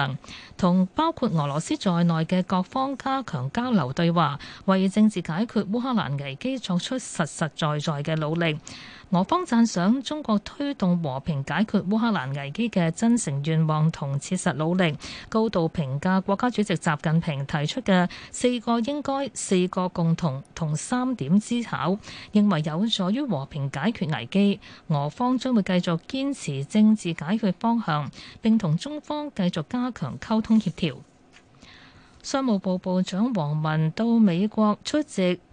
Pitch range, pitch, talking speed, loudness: 160-225 Hz, 185 Hz, 235 characters per minute, -25 LUFS